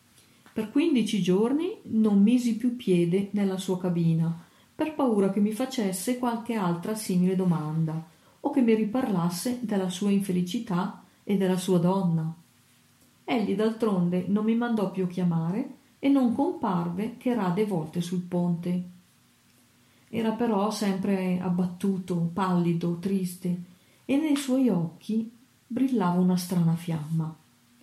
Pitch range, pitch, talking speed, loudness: 180-230 Hz, 195 Hz, 125 wpm, -27 LUFS